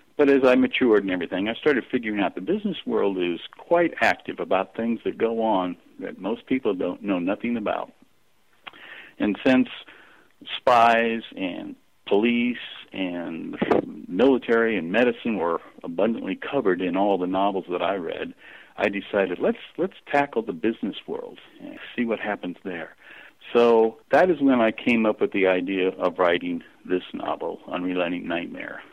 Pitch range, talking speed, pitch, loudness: 95-135 Hz, 160 wpm, 115 Hz, -24 LUFS